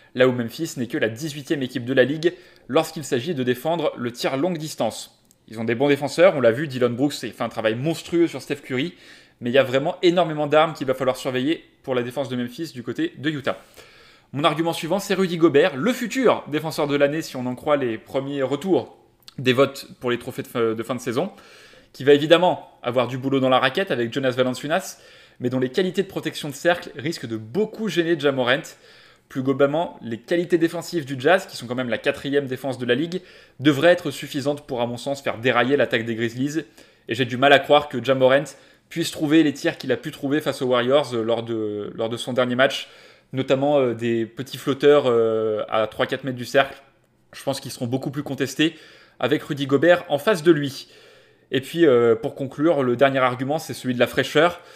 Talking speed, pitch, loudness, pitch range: 220 wpm, 140 Hz, -22 LUFS, 125-160 Hz